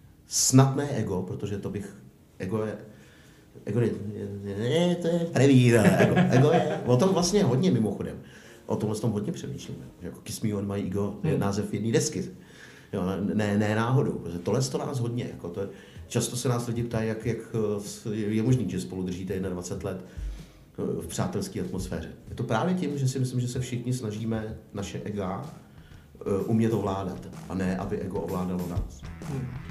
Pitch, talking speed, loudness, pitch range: 105 Hz, 180 wpm, -27 LUFS, 95-125 Hz